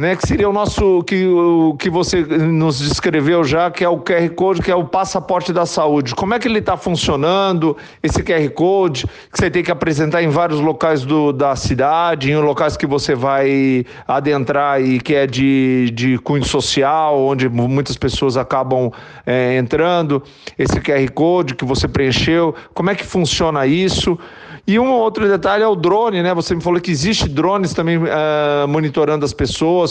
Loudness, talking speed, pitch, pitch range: -16 LUFS, 185 wpm, 160 Hz, 140-180 Hz